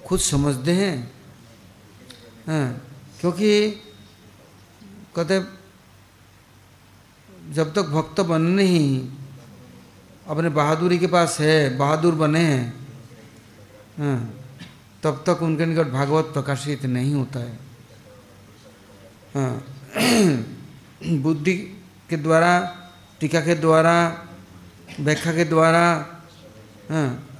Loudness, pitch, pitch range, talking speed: -21 LUFS, 145 Hz, 120-170 Hz, 80 wpm